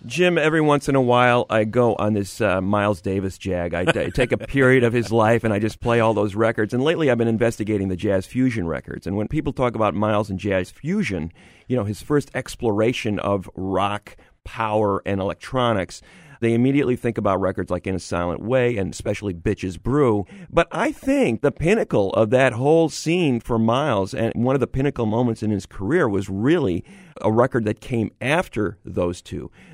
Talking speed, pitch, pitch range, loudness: 200 wpm, 110 Hz, 100-130 Hz, -21 LUFS